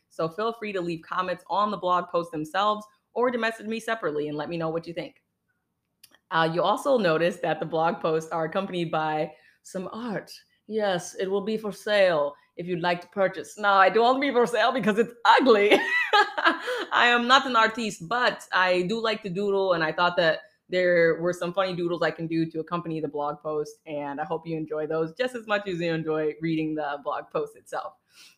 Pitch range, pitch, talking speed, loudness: 160-220 Hz, 180 Hz, 215 wpm, -25 LUFS